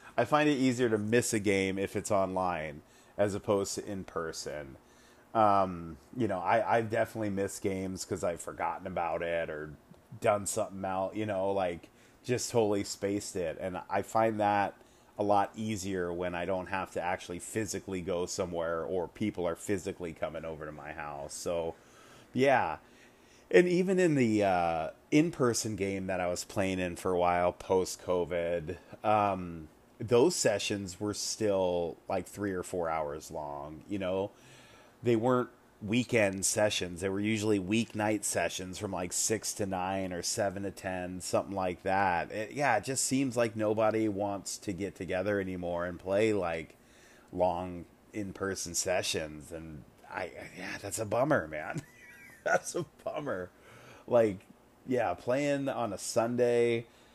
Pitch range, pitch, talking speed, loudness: 90-110 Hz, 100 Hz, 160 wpm, -32 LUFS